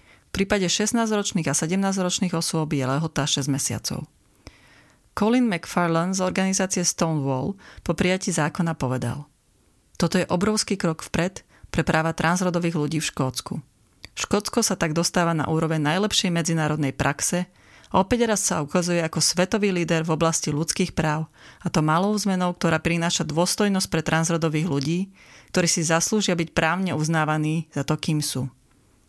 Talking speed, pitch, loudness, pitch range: 145 wpm, 170 Hz, -23 LUFS, 155-185 Hz